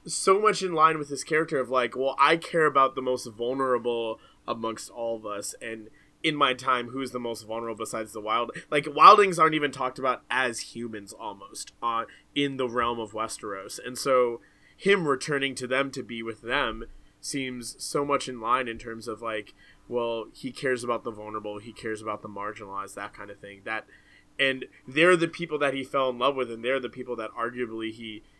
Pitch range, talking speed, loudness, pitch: 115-140 Hz, 205 wpm, -26 LUFS, 125 Hz